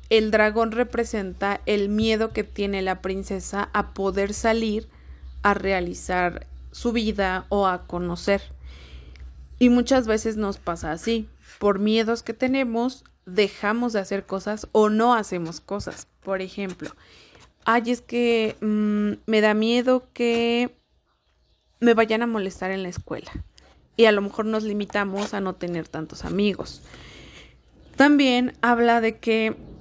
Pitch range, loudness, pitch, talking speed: 190-230 Hz, -23 LUFS, 210 Hz, 140 wpm